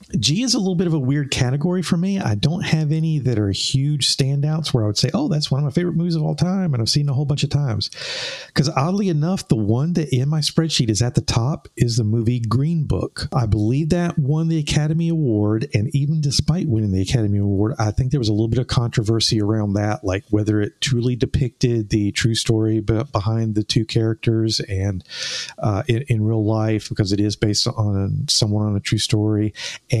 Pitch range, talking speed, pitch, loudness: 110-155 Hz, 230 wpm, 125 Hz, -20 LUFS